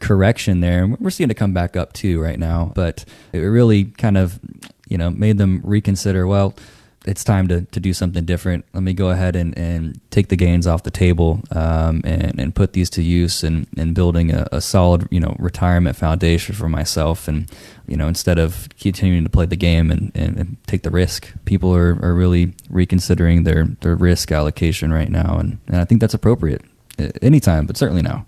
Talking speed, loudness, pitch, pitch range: 205 wpm, -18 LUFS, 90 Hz, 85-95 Hz